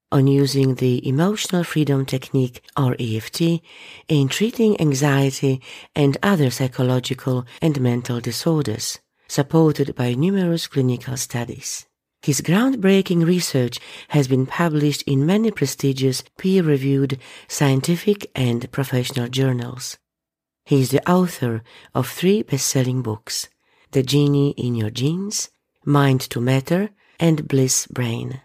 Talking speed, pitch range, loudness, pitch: 115 wpm, 130-160 Hz, -20 LUFS, 140 Hz